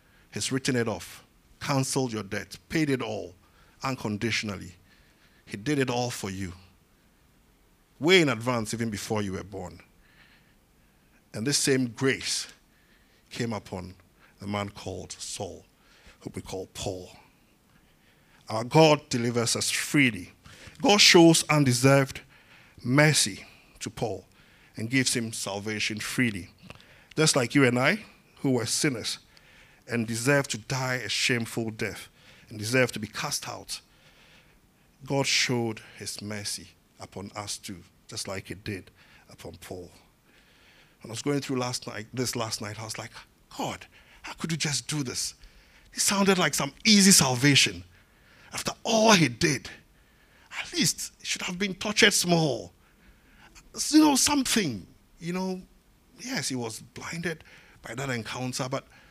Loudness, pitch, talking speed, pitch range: -25 LUFS, 120 Hz, 145 wpm, 105-145 Hz